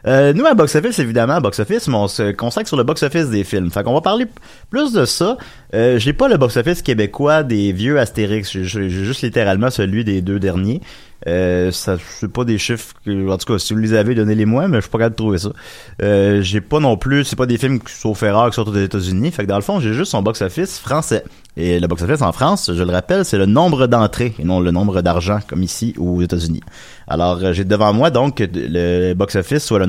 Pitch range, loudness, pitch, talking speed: 95-125 Hz, -16 LUFS, 105 Hz, 255 wpm